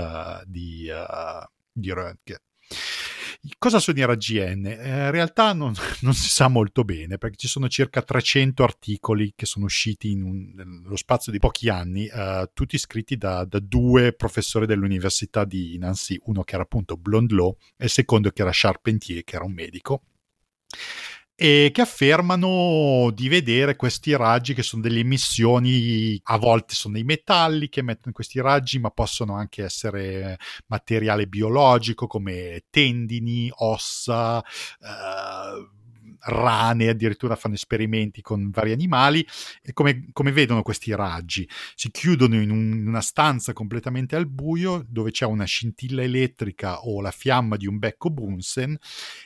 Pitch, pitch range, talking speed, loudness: 115 Hz, 100-130 Hz, 150 wpm, -22 LUFS